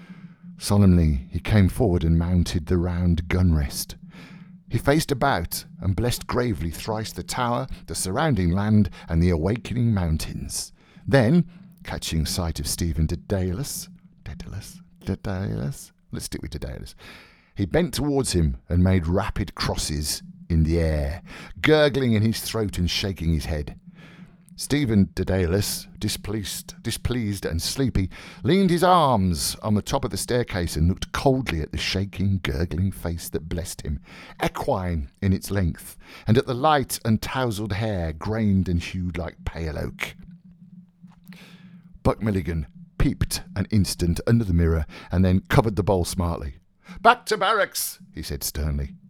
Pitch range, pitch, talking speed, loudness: 85-135 Hz, 95 Hz, 145 wpm, -24 LUFS